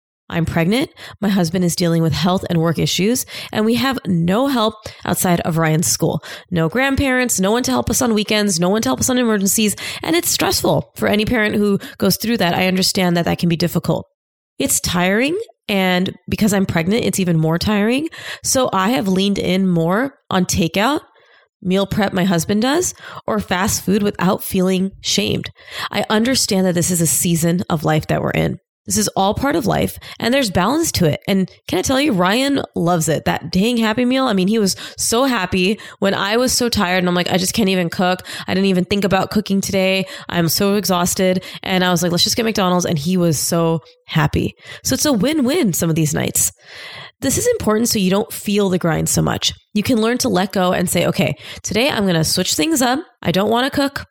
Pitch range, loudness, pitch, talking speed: 180-225 Hz, -17 LUFS, 195 Hz, 220 wpm